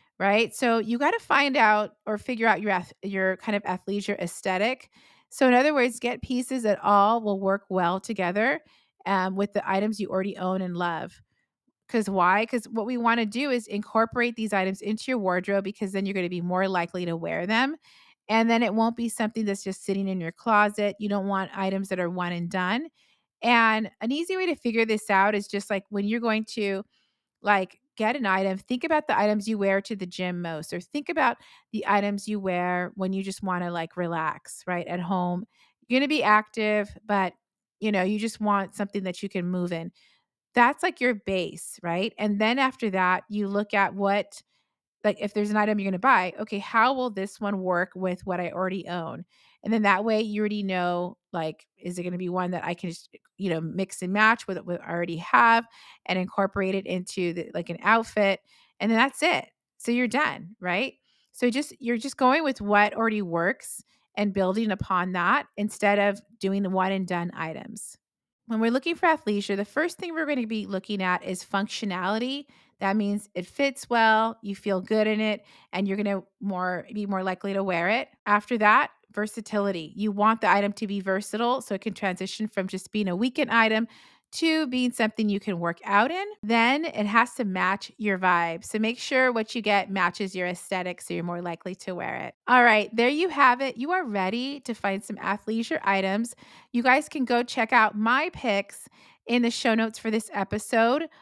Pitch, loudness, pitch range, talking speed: 205 Hz, -26 LUFS, 190-230 Hz, 215 wpm